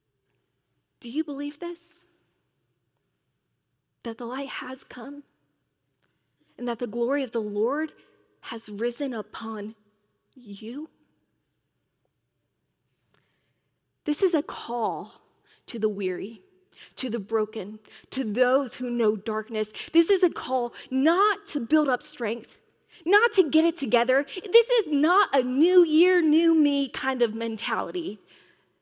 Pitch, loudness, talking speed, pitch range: 255 Hz, -25 LUFS, 125 wpm, 215-315 Hz